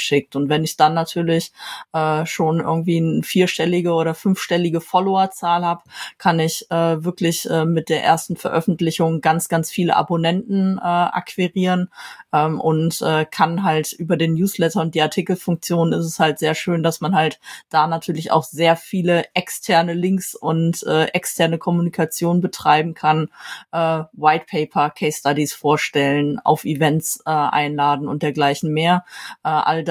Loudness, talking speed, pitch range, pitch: -19 LUFS, 155 wpm, 155-175 Hz, 165 Hz